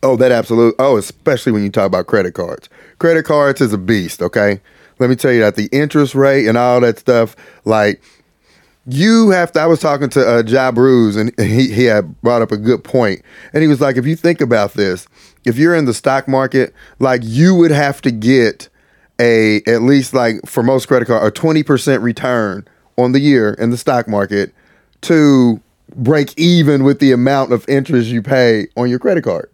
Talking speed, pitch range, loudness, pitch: 210 wpm, 115-140 Hz, -13 LUFS, 130 Hz